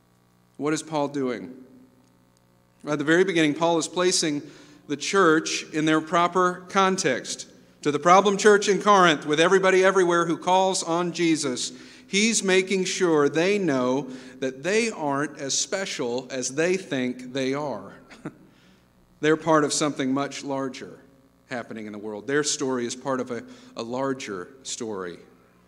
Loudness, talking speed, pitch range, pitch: -23 LUFS, 150 wpm, 130-180 Hz, 150 Hz